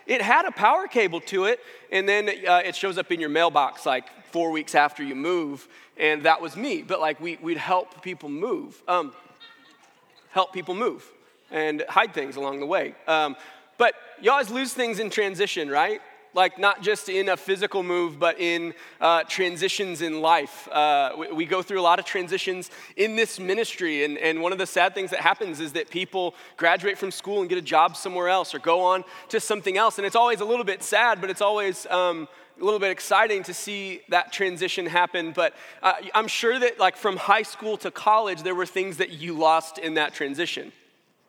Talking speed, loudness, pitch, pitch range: 210 wpm, -24 LUFS, 185 Hz, 170-215 Hz